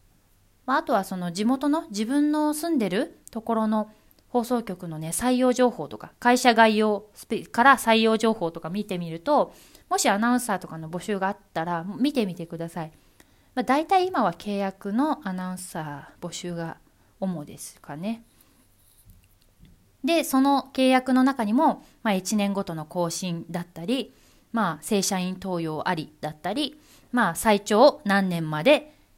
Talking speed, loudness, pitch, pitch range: 290 characters per minute, -24 LUFS, 205 Hz, 170-250 Hz